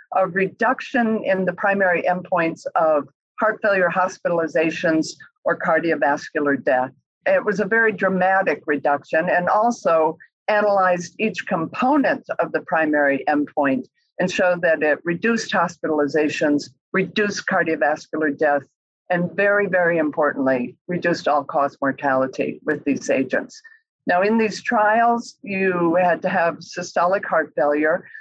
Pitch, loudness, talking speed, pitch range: 175 Hz, -20 LUFS, 125 wpm, 155-200 Hz